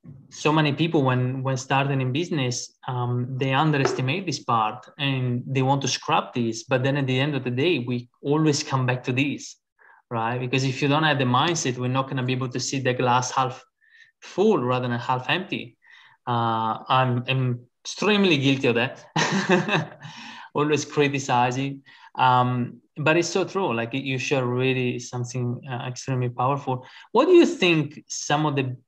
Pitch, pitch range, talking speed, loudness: 130 Hz, 125-150 Hz, 180 wpm, -23 LUFS